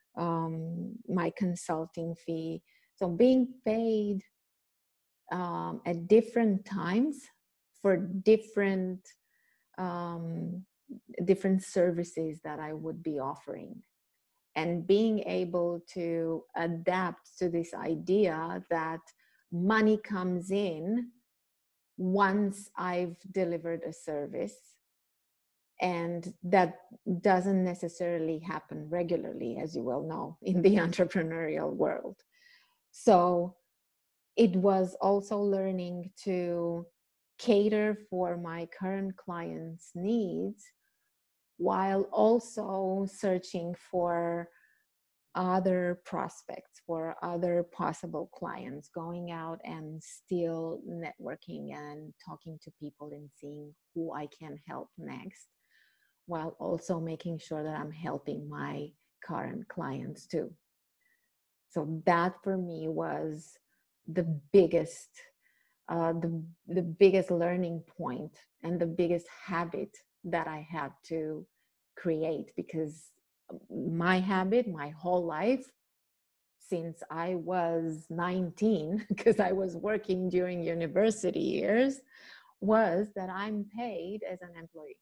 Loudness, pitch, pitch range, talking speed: -32 LUFS, 180 Hz, 165-195 Hz, 105 wpm